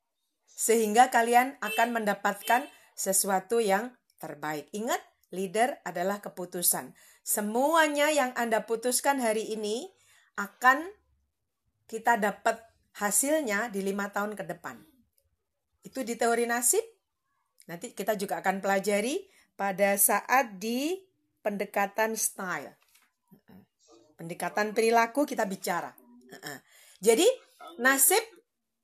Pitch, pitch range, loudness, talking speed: 220 Hz, 195-250 Hz, -27 LUFS, 95 wpm